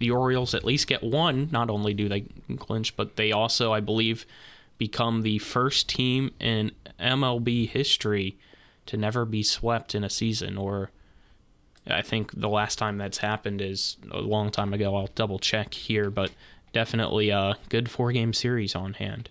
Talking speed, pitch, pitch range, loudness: 175 wpm, 110 Hz, 100-115 Hz, -26 LUFS